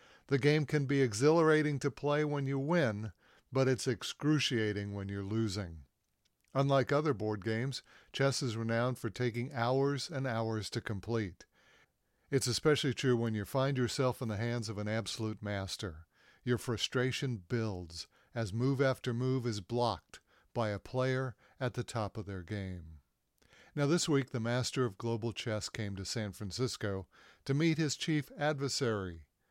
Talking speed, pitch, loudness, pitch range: 160 wpm, 120 Hz, -34 LUFS, 110-135 Hz